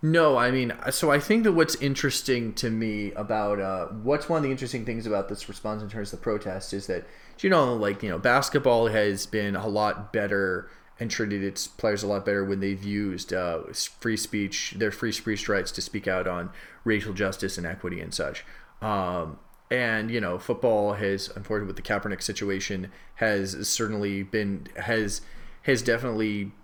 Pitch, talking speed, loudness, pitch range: 105 Hz, 190 wpm, -27 LUFS, 100-115 Hz